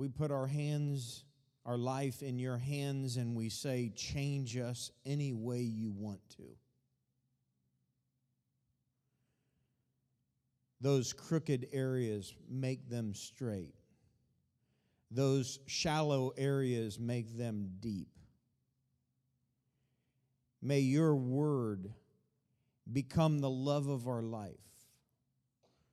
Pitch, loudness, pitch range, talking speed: 130 Hz, -37 LUFS, 120-135 Hz, 95 wpm